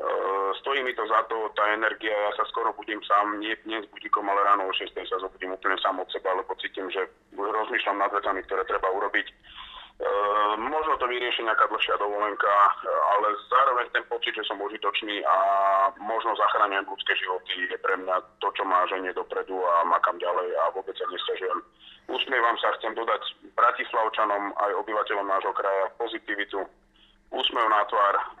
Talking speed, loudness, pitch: 175 wpm, -26 LUFS, 105 Hz